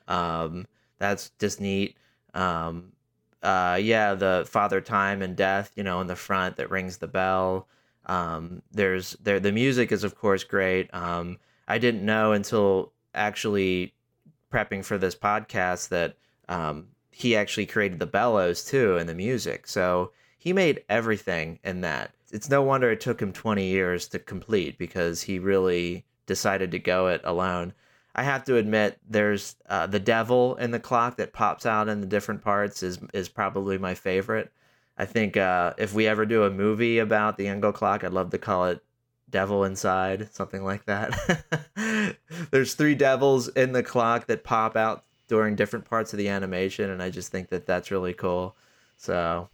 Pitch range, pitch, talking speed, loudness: 90-110 Hz, 100 Hz, 175 wpm, -26 LUFS